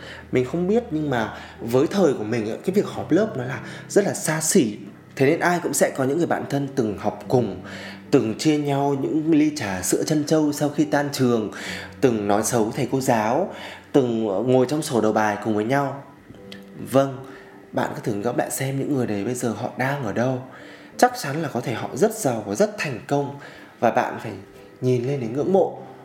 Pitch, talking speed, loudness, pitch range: 125 Hz, 220 wpm, -22 LUFS, 105-140 Hz